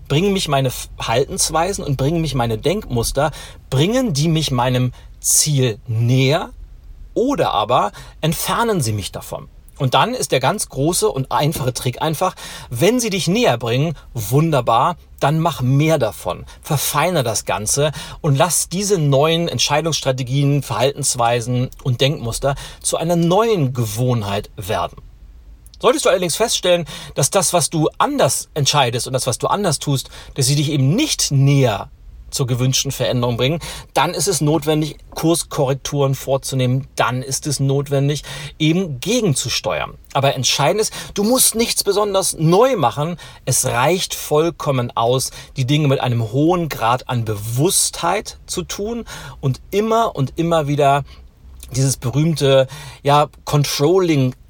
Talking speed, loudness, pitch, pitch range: 140 wpm, -18 LUFS, 140 Hz, 125-165 Hz